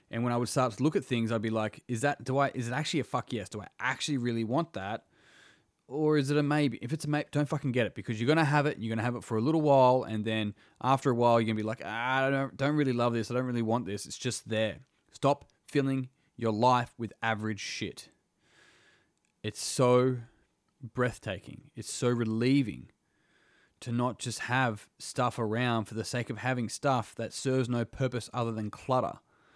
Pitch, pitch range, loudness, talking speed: 125 Hz, 115-135 Hz, -30 LUFS, 220 wpm